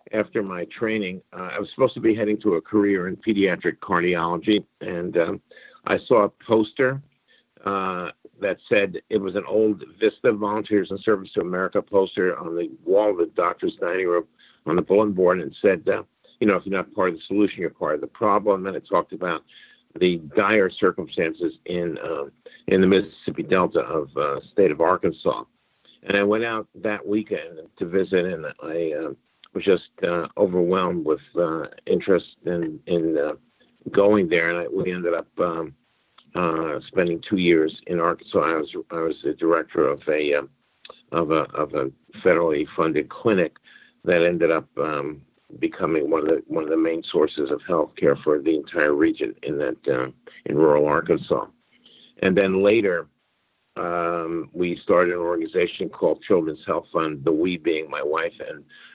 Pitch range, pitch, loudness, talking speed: 85-110 Hz, 100 Hz, -23 LUFS, 180 wpm